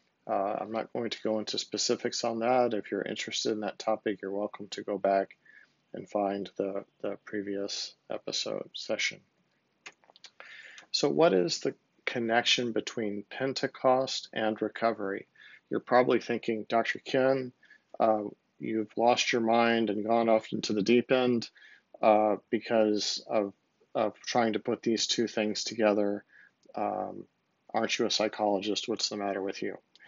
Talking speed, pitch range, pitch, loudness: 150 wpm, 105-120 Hz, 110 Hz, -30 LUFS